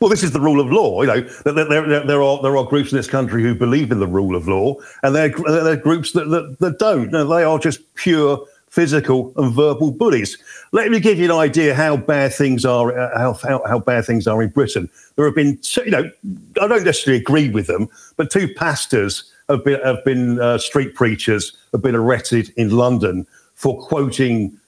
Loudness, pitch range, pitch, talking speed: -17 LUFS, 120-155 Hz, 140 Hz, 225 wpm